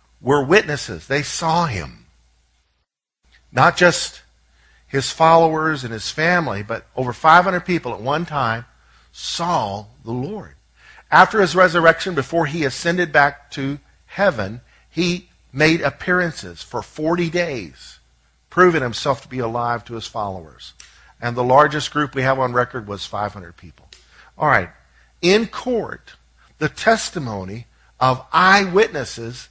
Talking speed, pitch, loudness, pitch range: 130 wpm, 135 Hz, -18 LUFS, 110-170 Hz